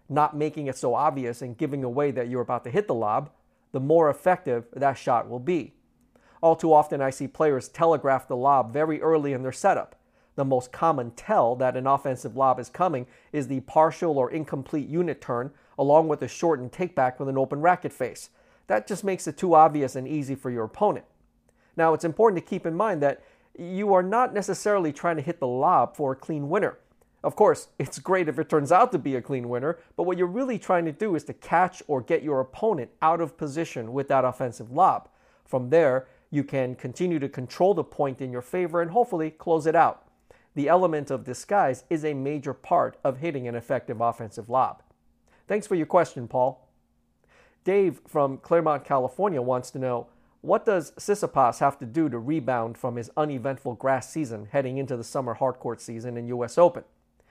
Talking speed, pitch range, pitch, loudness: 205 wpm, 125-165 Hz, 140 Hz, -25 LUFS